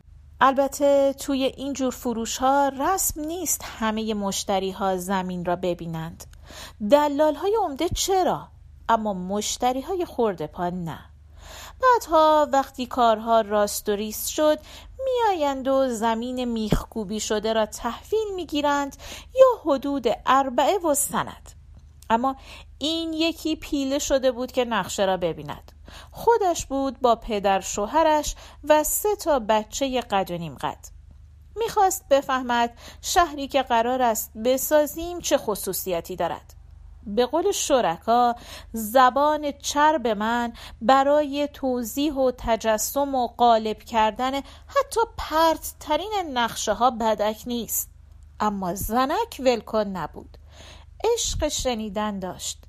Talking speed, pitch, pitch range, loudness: 120 wpm, 250 Hz, 215-295 Hz, -23 LUFS